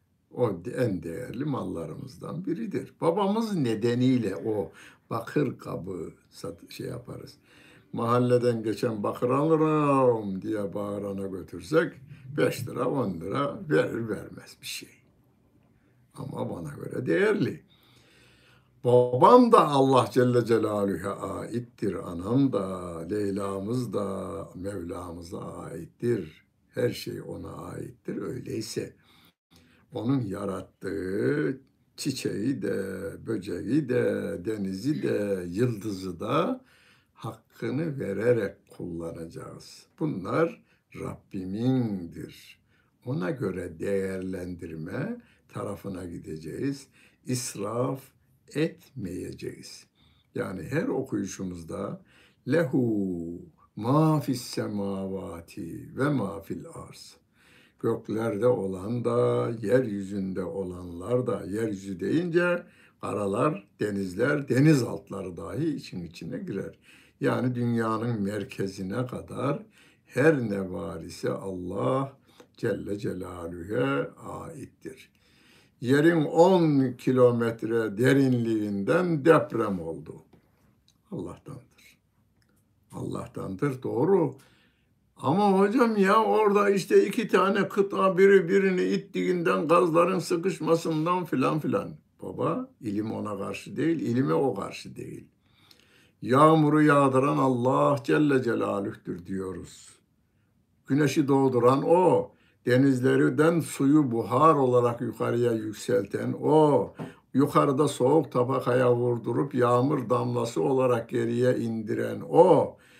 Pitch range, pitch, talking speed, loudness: 100-140 Hz, 120 Hz, 90 wpm, -26 LUFS